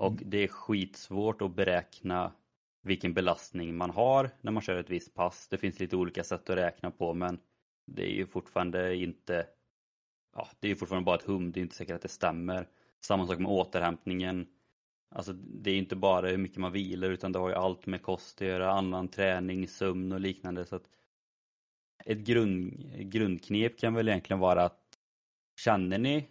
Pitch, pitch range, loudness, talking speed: 95 Hz, 90-100 Hz, -32 LUFS, 190 wpm